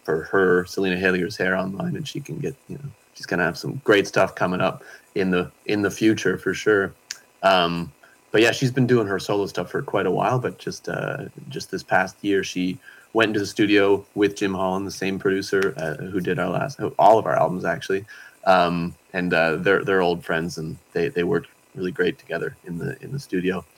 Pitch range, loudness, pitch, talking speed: 90-110 Hz, -22 LUFS, 95 Hz, 220 wpm